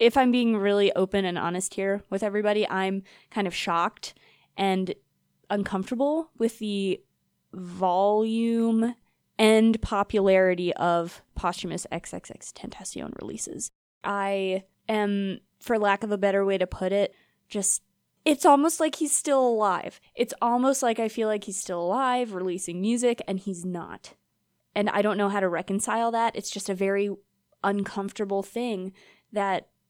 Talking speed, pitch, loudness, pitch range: 145 wpm, 200 Hz, -26 LUFS, 190-230 Hz